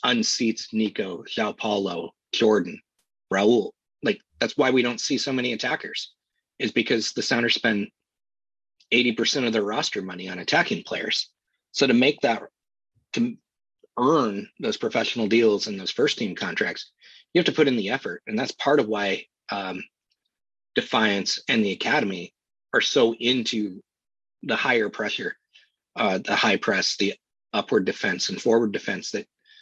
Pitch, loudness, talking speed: 120 Hz, -24 LUFS, 155 wpm